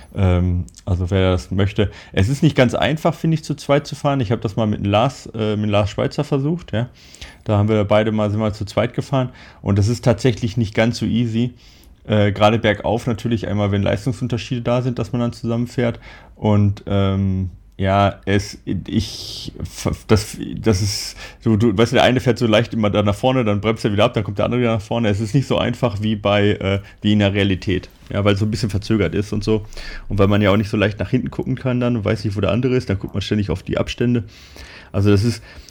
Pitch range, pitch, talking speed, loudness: 100-120 Hz, 110 Hz, 240 wpm, -19 LUFS